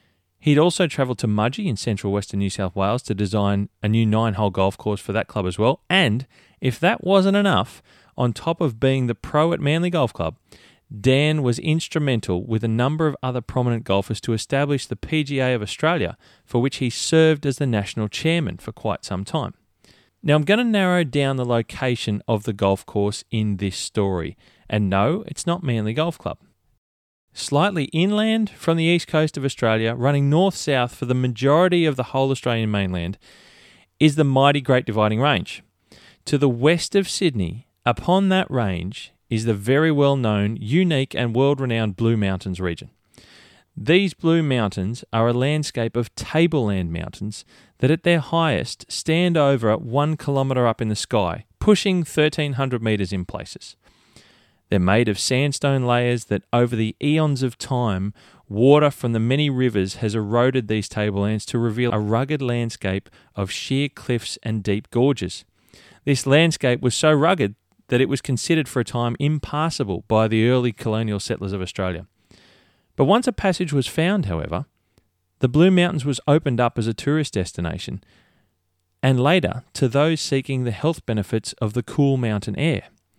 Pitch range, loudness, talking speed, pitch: 105-145 Hz, -21 LUFS, 175 wpm, 125 Hz